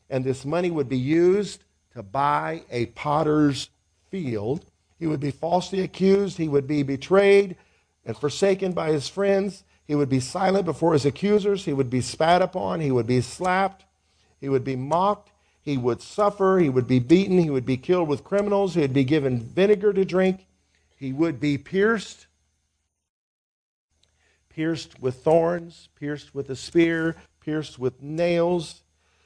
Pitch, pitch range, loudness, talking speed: 150 Hz, 130-180 Hz, -23 LUFS, 160 wpm